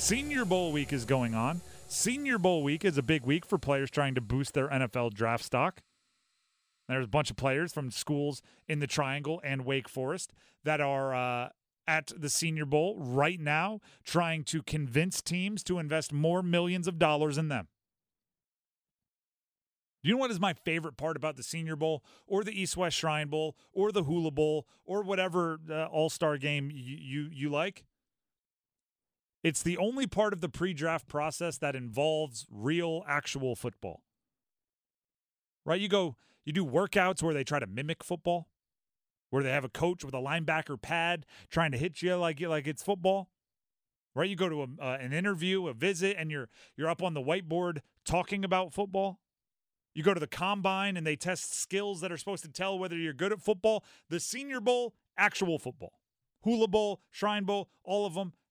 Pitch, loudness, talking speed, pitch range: 160 Hz, -32 LUFS, 185 wpm, 145-185 Hz